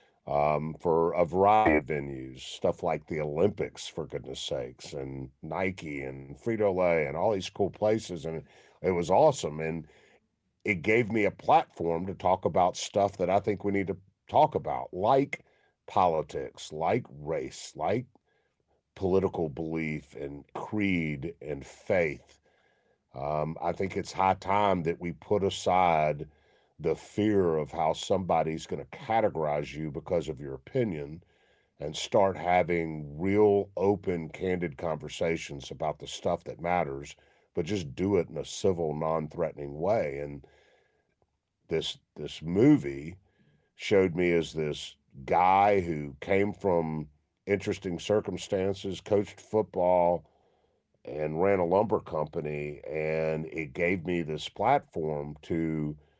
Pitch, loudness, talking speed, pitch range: 85 Hz, -29 LUFS, 135 wpm, 75-95 Hz